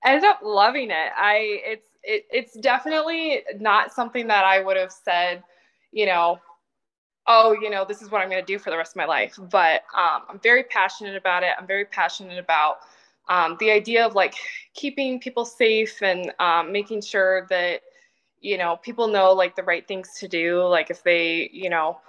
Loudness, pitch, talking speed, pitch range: -21 LUFS, 195 Hz, 195 wpm, 180-235 Hz